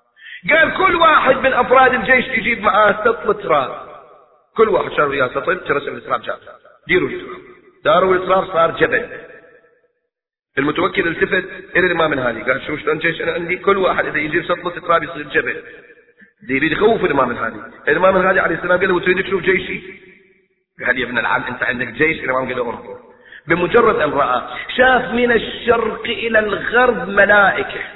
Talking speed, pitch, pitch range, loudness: 160 wpm, 210 Hz, 180-265 Hz, -16 LUFS